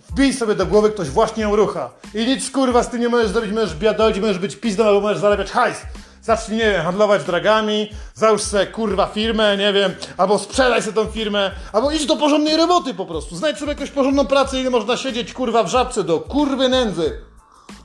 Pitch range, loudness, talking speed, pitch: 205-255 Hz, -18 LUFS, 210 wpm, 220 Hz